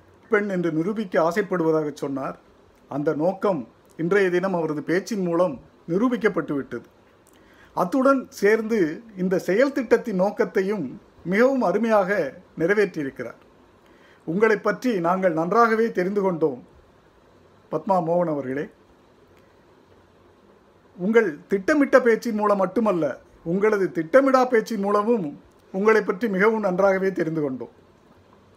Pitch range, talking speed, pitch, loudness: 165-220 Hz, 95 wpm, 195 Hz, -22 LUFS